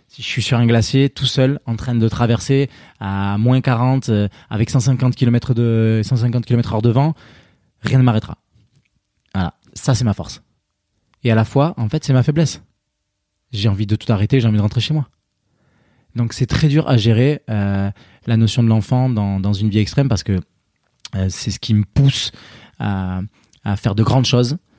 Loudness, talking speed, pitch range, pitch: -17 LUFS, 200 wpm, 105-130 Hz, 115 Hz